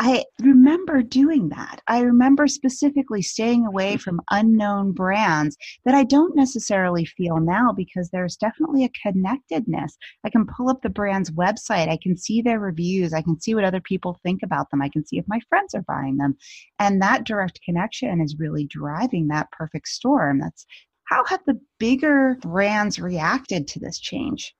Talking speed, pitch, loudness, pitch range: 180 wpm, 205 Hz, -21 LUFS, 175-255 Hz